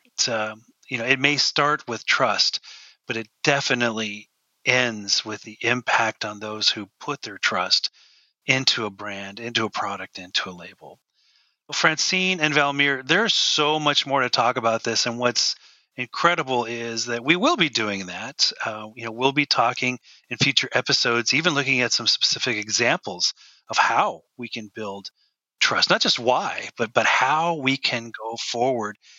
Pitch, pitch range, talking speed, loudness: 120 Hz, 110-140 Hz, 170 wpm, -21 LUFS